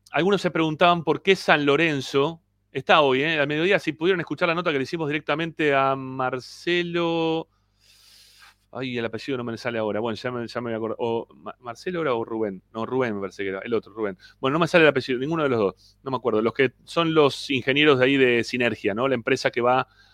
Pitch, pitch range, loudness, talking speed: 130 Hz, 115-155 Hz, -23 LUFS, 225 wpm